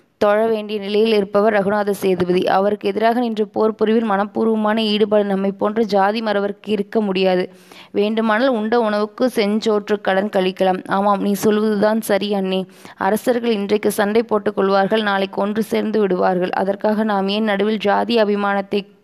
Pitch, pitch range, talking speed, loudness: 210 Hz, 195-215 Hz, 140 wpm, -18 LUFS